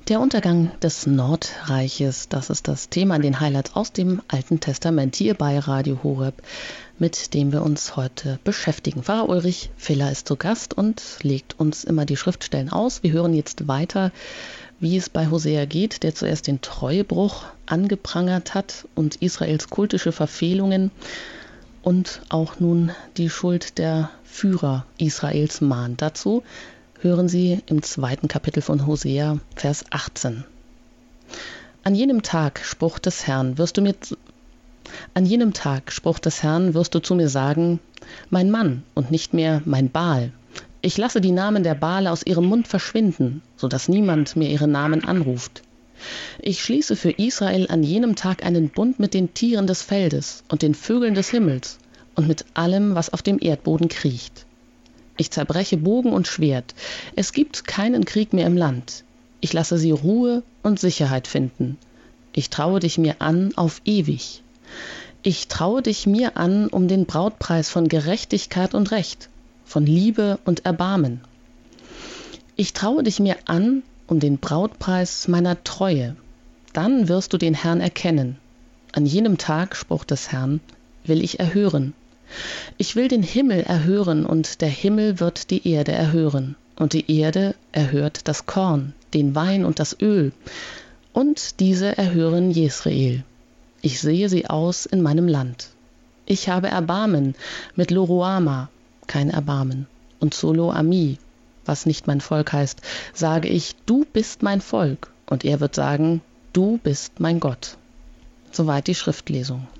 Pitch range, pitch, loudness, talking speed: 145-190 Hz, 165 Hz, -21 LUFS, 155 wpm